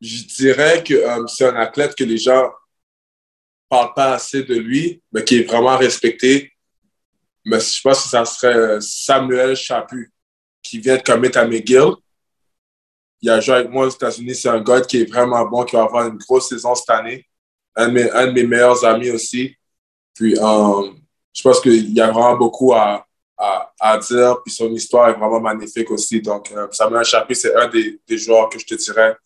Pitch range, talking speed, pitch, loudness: 110-130 Hz, 200 wpm, 120 Hz, -15 LUFS